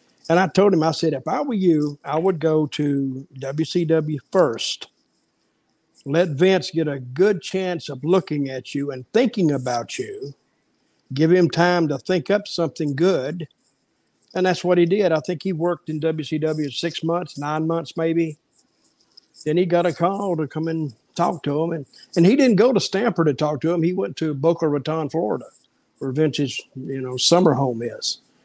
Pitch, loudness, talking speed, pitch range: 160 Hz, -21 LUFS, 190 wpm, 150-175 Hz